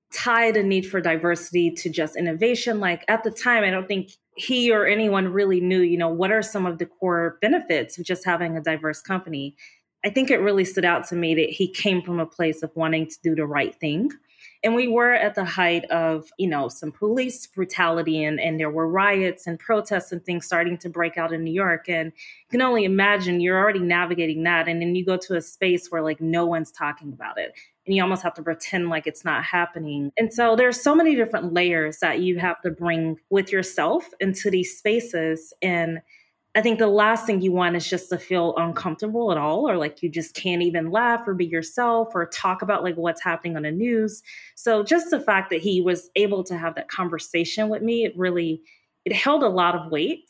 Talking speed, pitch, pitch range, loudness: 225 wpm, 180 Hz, 165-210 Hz, -22 LUFS